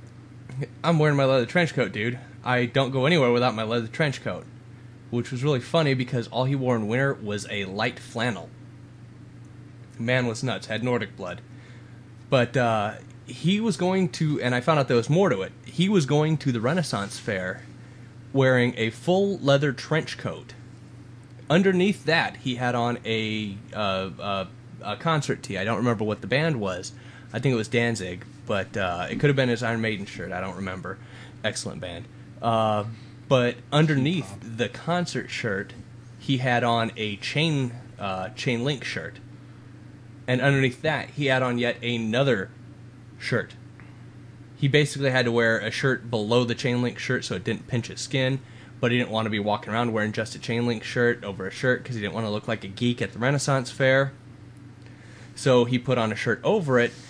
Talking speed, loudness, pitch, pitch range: 190 wpm, -25 LUFS, 125 Hz, 115-130 Hz